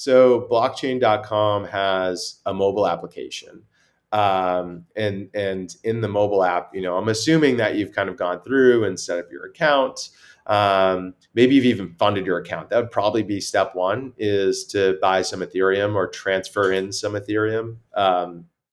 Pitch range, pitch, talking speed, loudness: 95-115 Hz, 100 Hz, 165 wpm, -21 LUFS